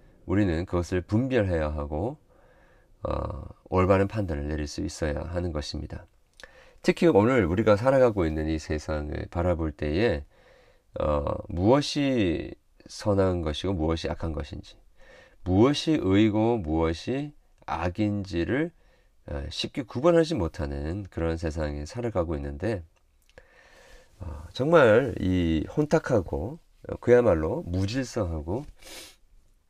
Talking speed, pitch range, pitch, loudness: 245 characters per minute, 80-115 Hz, 95 Hz, -26 LUFS